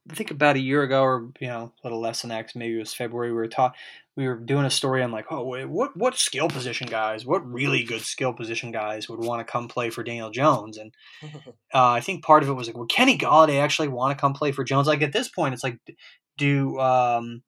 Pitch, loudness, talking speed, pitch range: 130 Hz, -24 LUFS, 260 wpm, 115-145 Hz